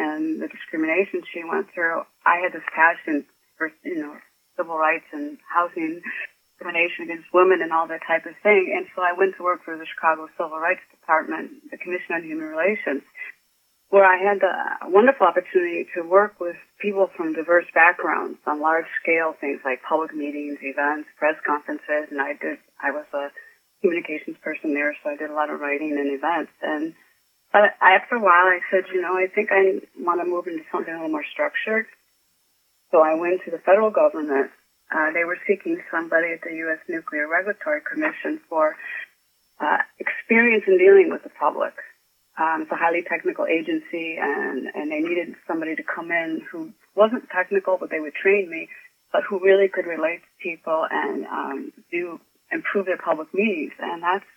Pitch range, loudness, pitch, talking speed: 160-240 Hz, -22 LUFS, 175 Hz, 185 wpm